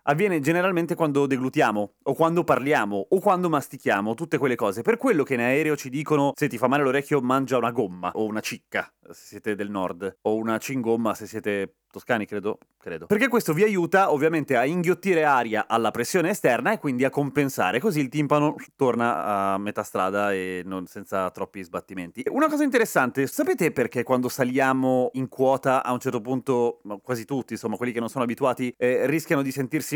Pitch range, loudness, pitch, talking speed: 110-150 Hz, -24 LUFS, 130 Hz, 190 wpm